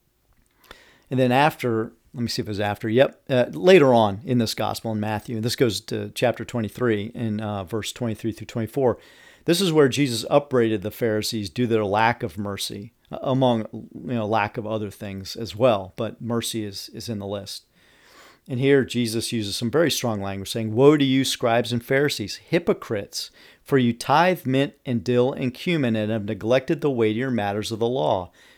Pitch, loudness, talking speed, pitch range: 115 Hz, -23 LUFS, 195 wpm, 110-130 Hz